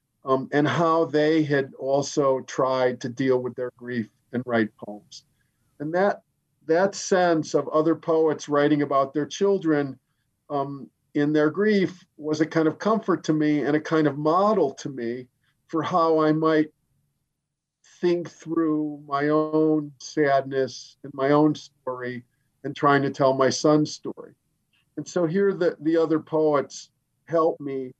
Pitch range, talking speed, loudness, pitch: 135-160 Hz, 155 wpm, -24 LUFS, 145 Hz